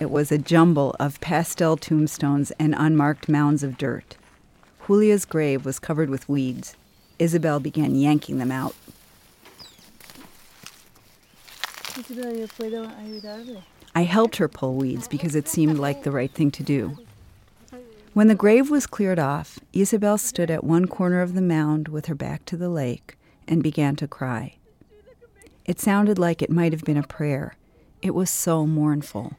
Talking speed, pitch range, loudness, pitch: 150 wpm, 145-185 Hz, -22 LUFS, 160 Hz